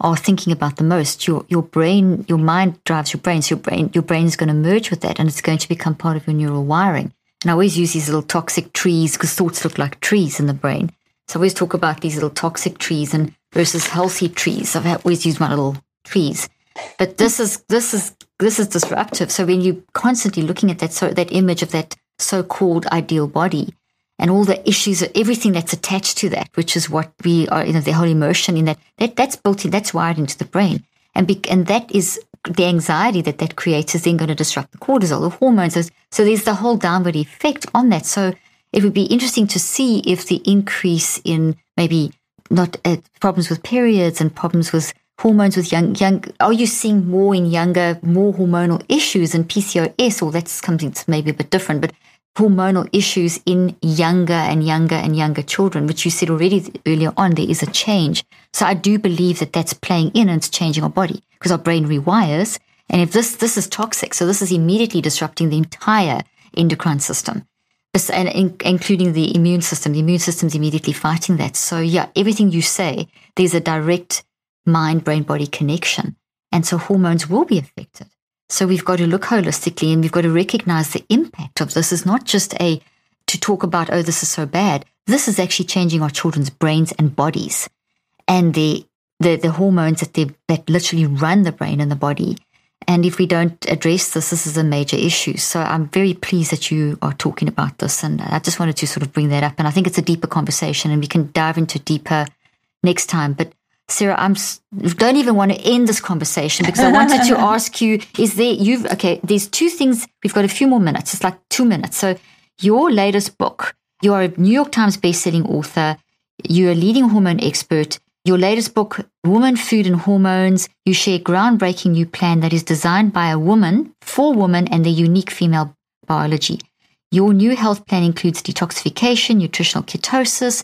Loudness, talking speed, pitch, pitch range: -17 LUFS, 210 wpm, 175 Hz, 160-195 Hz